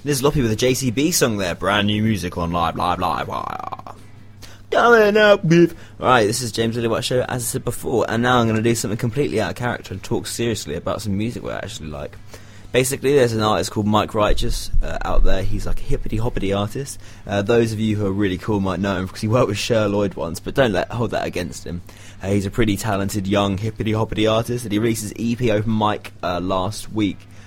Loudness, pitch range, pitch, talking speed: -20 LUFS, 100-120 Hz, 105 Hz, 240 wpm